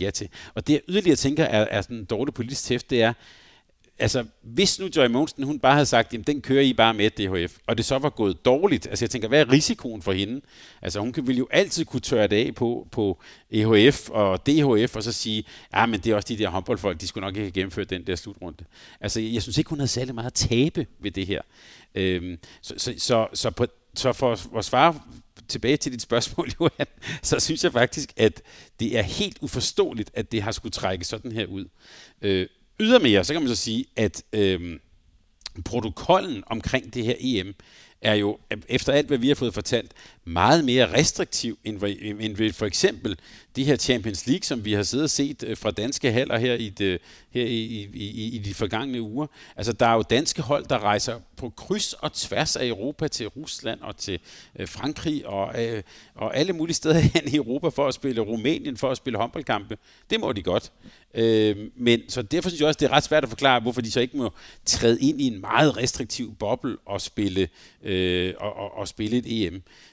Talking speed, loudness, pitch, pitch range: 215 wpm, -24 LUFS, 115 Hz, 105-135 Hz